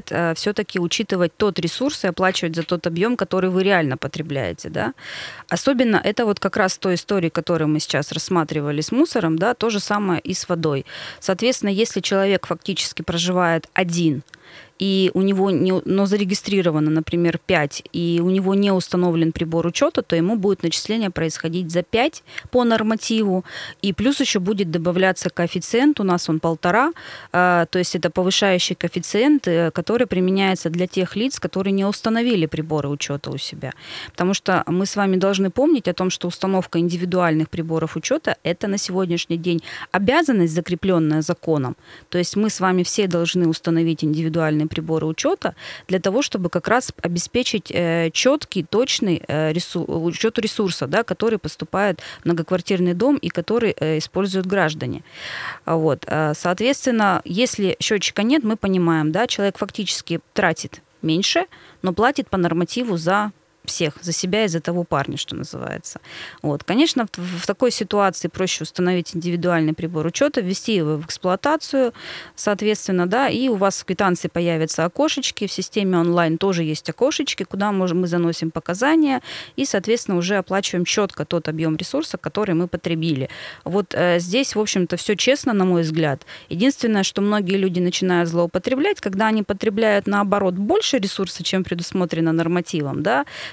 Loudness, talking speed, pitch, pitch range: -20 LUFS, 155 wpm, 185 Hz, 170-205 Hz